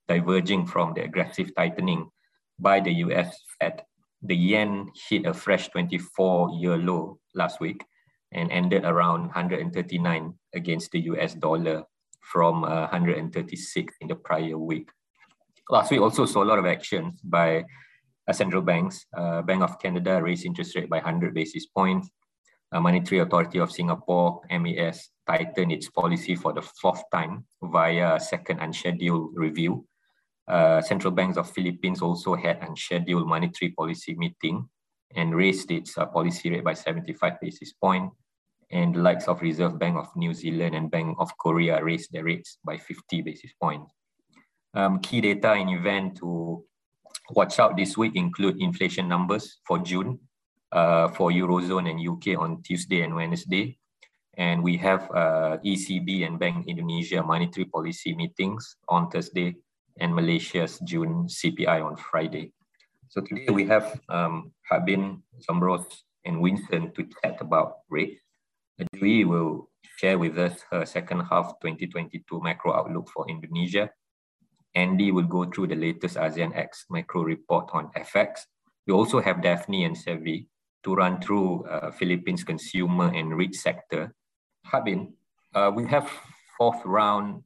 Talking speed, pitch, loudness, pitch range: 145 wpm, 90 Hz, -26 LUFS, 85-105 Hz